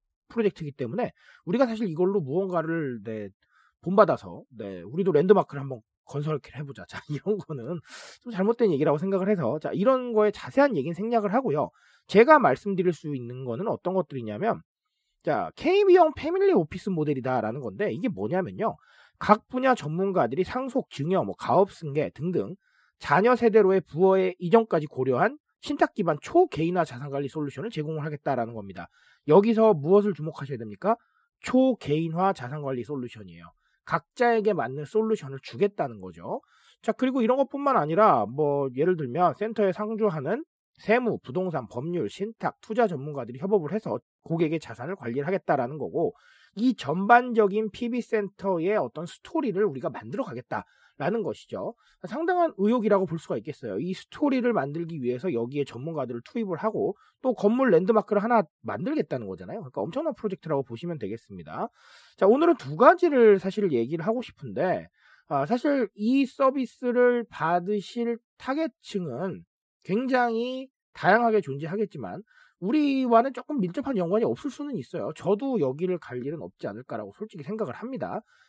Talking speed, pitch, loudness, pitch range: 370 characters per minute, 200 Hz, -26 LUFS, 155-240 Hz